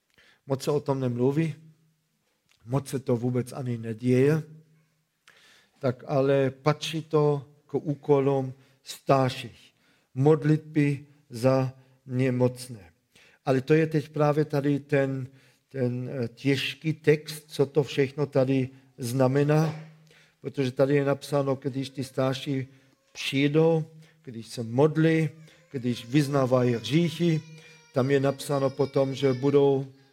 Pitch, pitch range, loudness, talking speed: 140 Hz, 130-150 Hz, -26 LUFS, 110 wpm